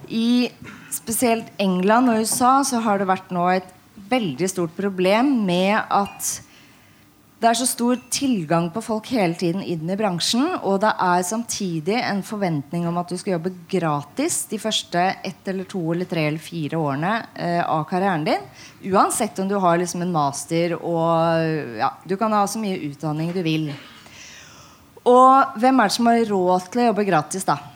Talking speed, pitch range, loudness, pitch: 180 wpm, 170-225 Hz, -21 LUFS, 190 Hz